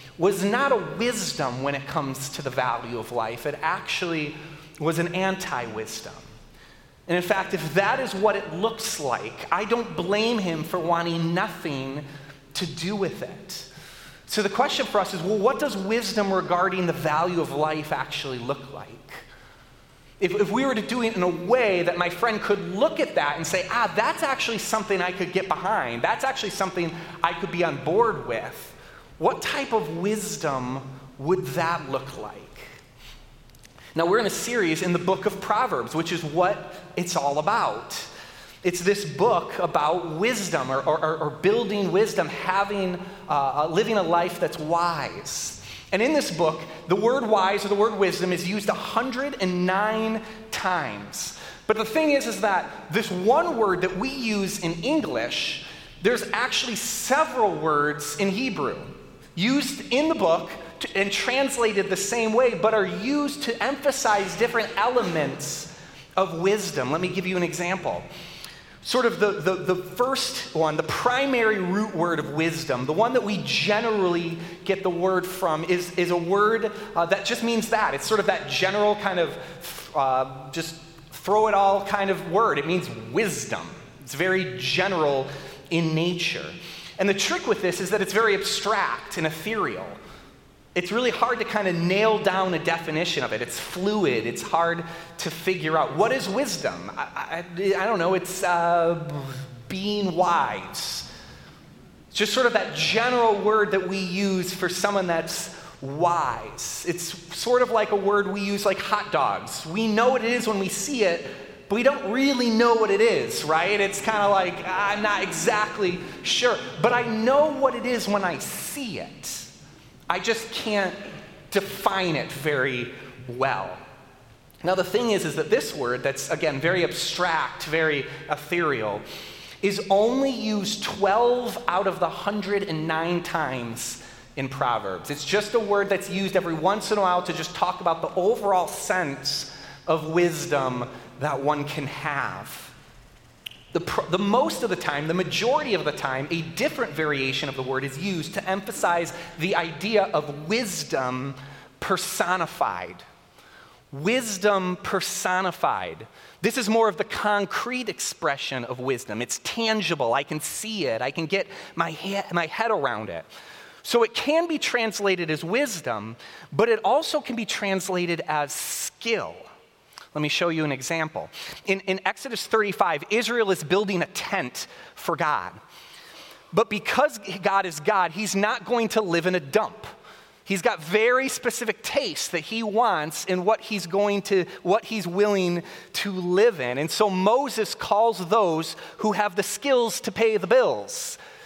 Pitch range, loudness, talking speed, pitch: 165-215 Hz, -24 LUFS, 165 wpm, 185 Hz